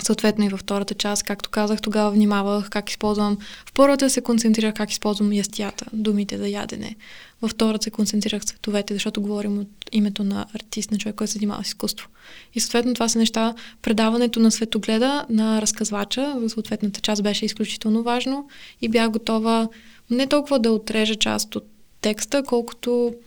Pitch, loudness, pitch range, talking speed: 215 Hz, -22 LUFS, 210-230 Hz, 170 wpm